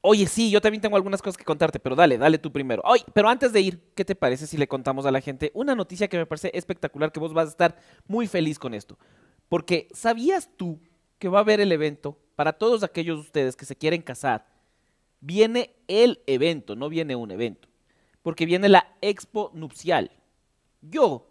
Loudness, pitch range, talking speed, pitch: -24 LUFS, 150-200 Hz, 210 wpm, 170 Hz